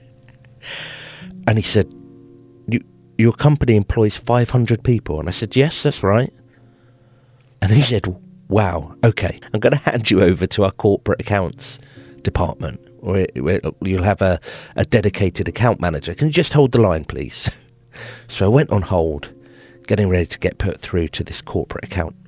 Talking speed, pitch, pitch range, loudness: 165 wpm, 105 Hz, 90-125 Hz, -18 LUFS